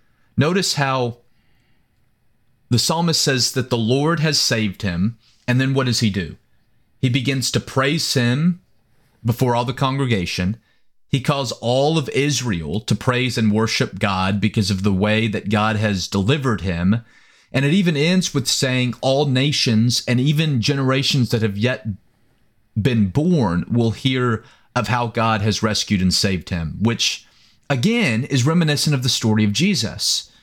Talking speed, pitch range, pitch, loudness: 160 wpm, 110-135 Hz, 120 Hz, -19 LUFS